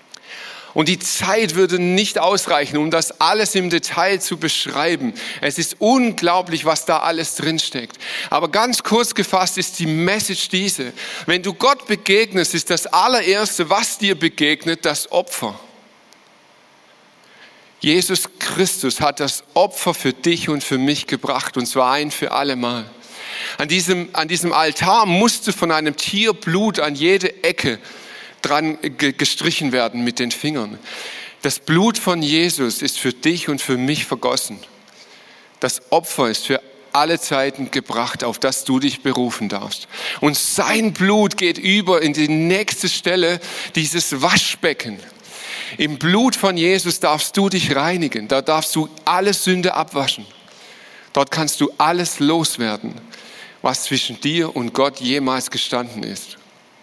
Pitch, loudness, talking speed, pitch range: 165 Hz, -18 LUFS, 145 wpm, 145-190 Hz